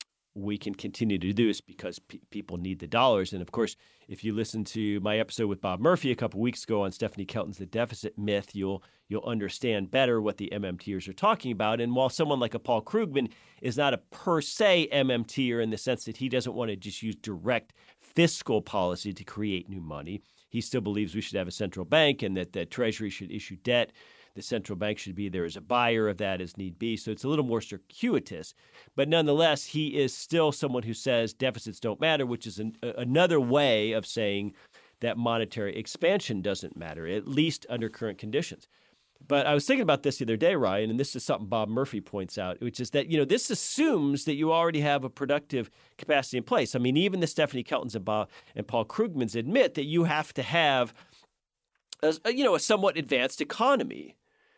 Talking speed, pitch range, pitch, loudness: 215 wpm, 105-140 Hz, 115 Hz, -29 LUFS